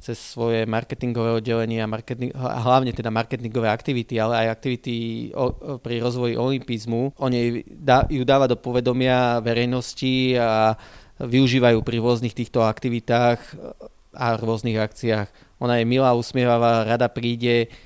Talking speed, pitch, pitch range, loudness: 130 wpm, 120 Hz, 115-125 Hz, -22 LUFS